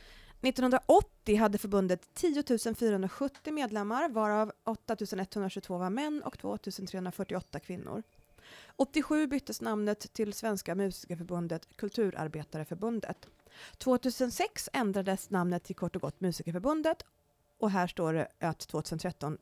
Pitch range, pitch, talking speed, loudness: 180-250 Hz, 205 Hz, 110 wpm, -33 LUFS